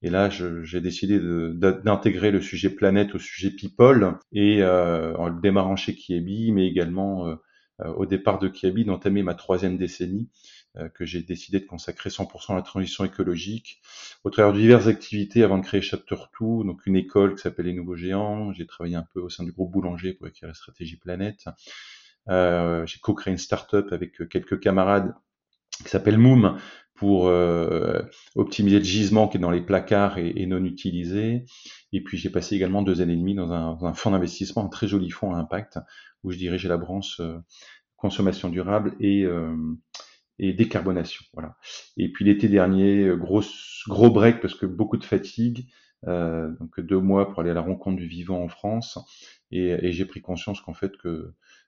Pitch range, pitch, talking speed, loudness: 90-100 Hz, 95 Hz, 195 wpm, -23 LUFS